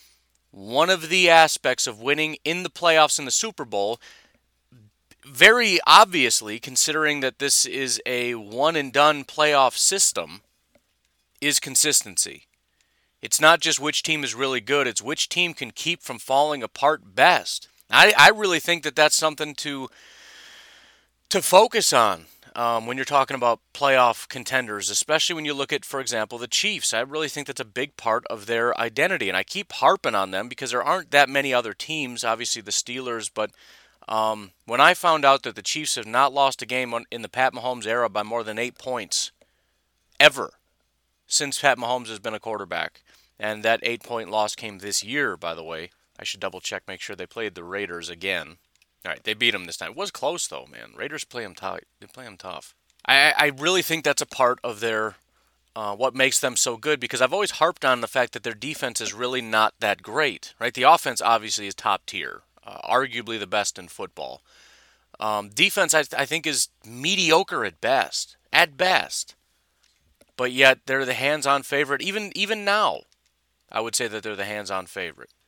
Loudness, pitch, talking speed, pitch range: -21 LUFS, 130 Hz, 195 wpm, 110-150 Hz